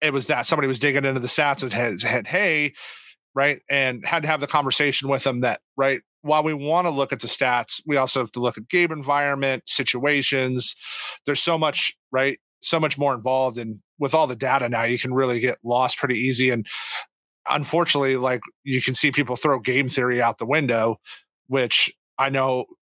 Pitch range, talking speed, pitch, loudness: 125-145 Hz, 205 wpm, 135 Hz, -21 LUFS